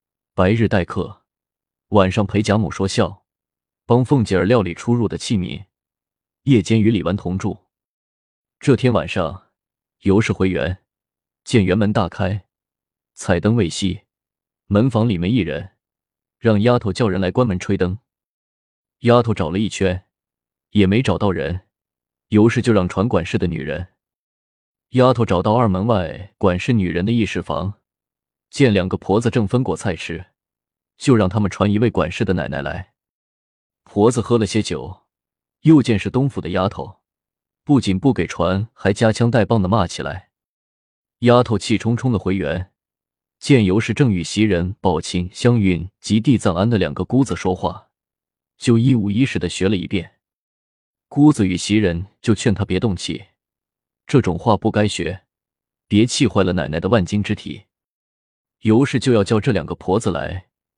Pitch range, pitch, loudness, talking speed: 90-115 Hz, 100 Hz, -18 LUFS, 225 characters per minute